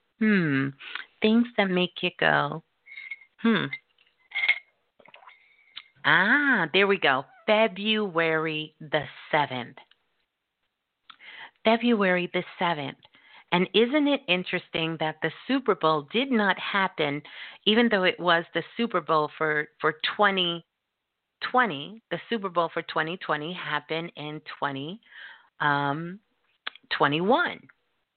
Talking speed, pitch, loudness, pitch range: 110 wpm, 180 Hz, -25 LUFS, 155-220 Hz